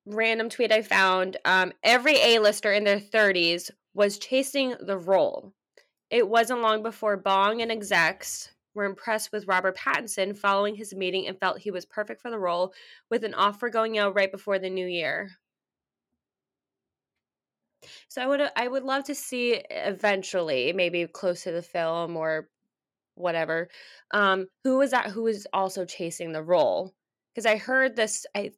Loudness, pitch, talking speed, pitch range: -25 LUFS, 205 Hz, 165 wpm, 185-230 Hz